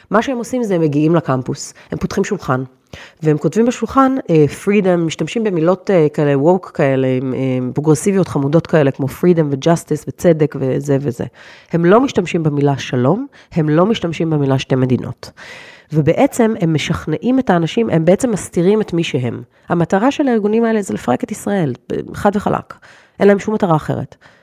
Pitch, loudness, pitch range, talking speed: 170 Hz, -16 LUFS, 145-205 Hz, 160 wpm